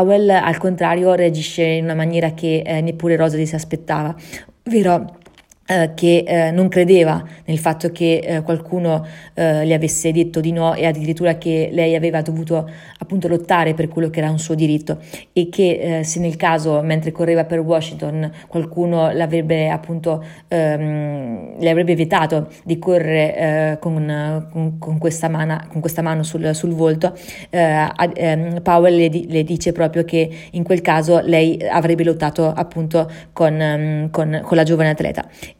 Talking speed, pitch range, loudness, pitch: 165 wpm, 160-170 Hz, -17 LUFS, 165 Hz